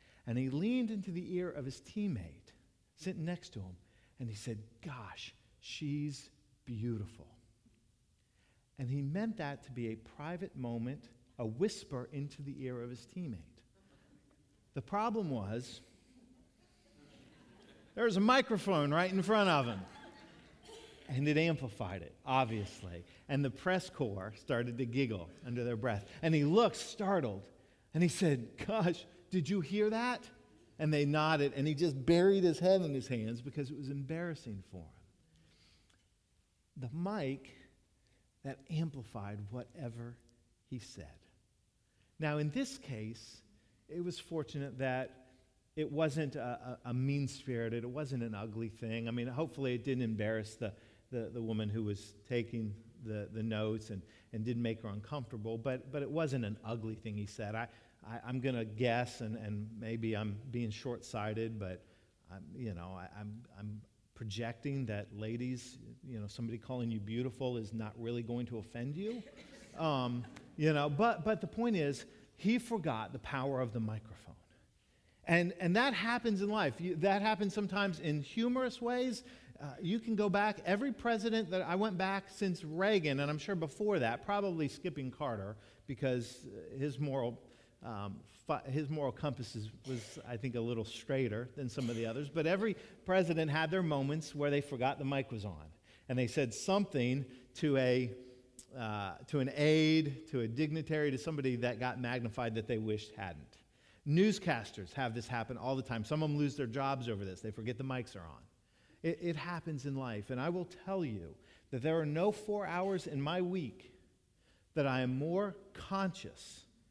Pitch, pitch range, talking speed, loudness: 130 Hz, 115-160 Hz, 170 wpm, -37 LUFS